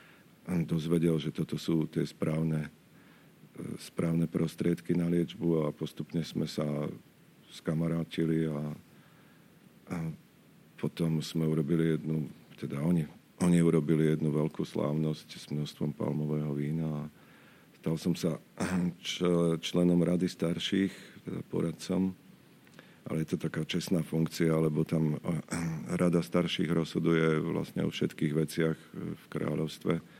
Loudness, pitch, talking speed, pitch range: -32 LUFS, 80 Hz, 115 wpm, 80-85 Hz